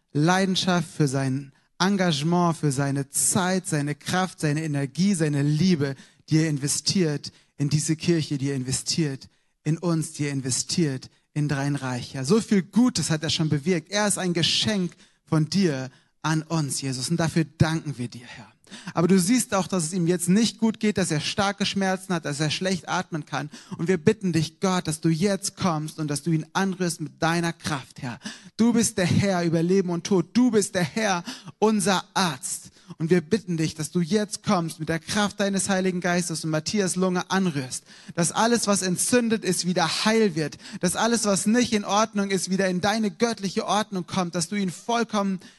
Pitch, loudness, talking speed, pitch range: 175 Hz, -24 LUFS, 195 wpm, 155-195 Hz